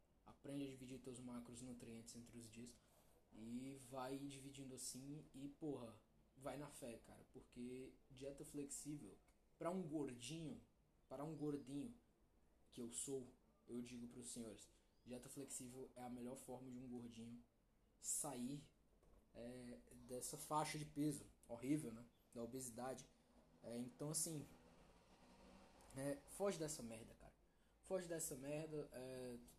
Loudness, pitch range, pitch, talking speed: -52 LUFS, 120-140 Hz, 125 Hz, 140 wpm